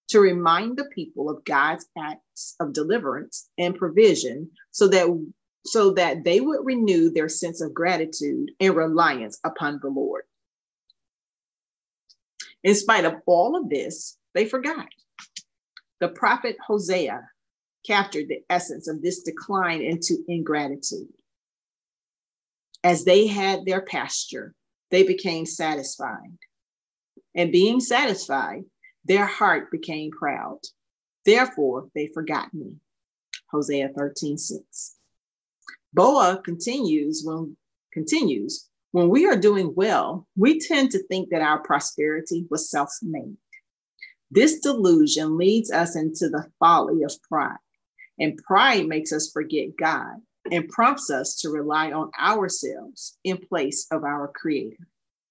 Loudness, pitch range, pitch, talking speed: -23 LUFS, 155-210 Hz, 175 Hz, 120 wpm